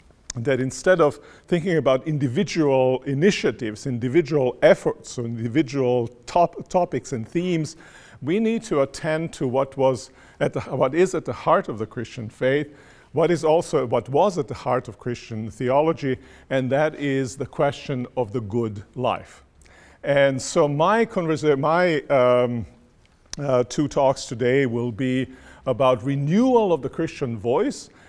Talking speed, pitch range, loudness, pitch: 150 wpm, 125-160 Hz, -22 LUFS, 135 Hz